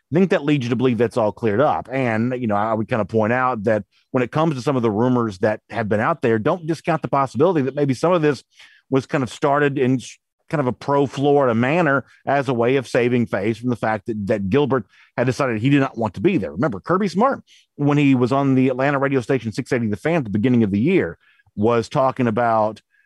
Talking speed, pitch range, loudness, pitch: 250 wpm, 115-145 Hz, -20 LUFS, 130 Hz